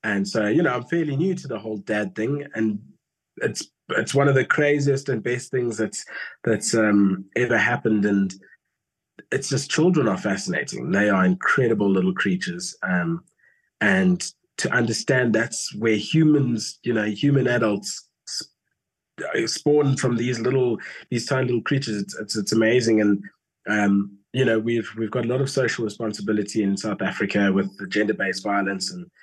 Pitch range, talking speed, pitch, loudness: 105-140 Hz, 170 wpm, 115 Hz, -22 LUFS